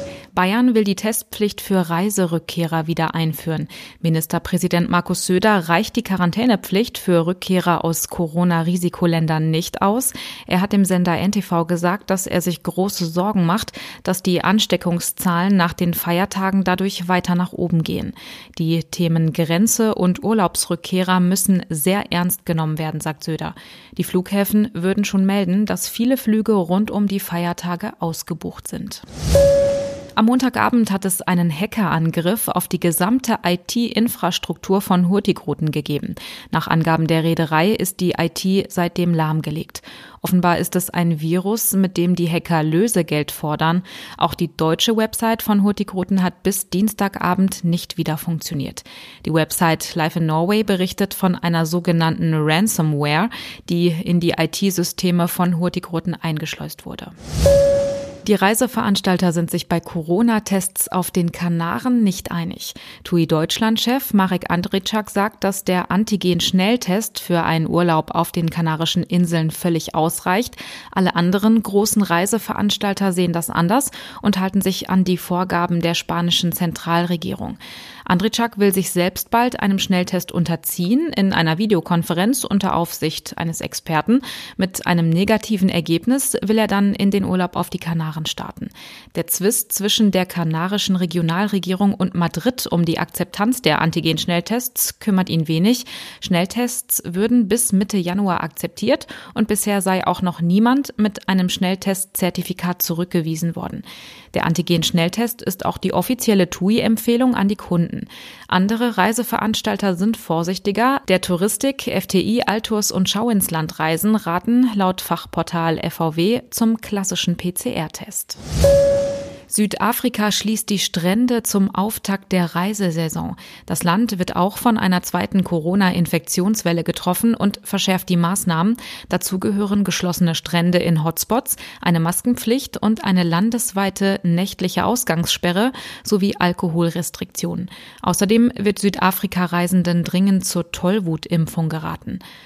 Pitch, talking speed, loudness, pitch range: 185 Hz, 130 wpm, -19 LUFS, 170-210 Hz